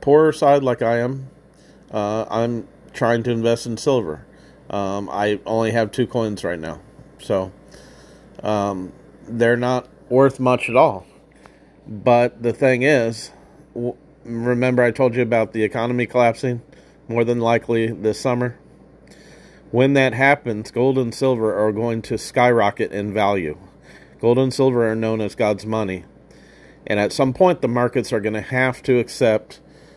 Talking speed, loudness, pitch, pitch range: 155 wpm, -19 LUFS, 120 Hz, 110-125 Hz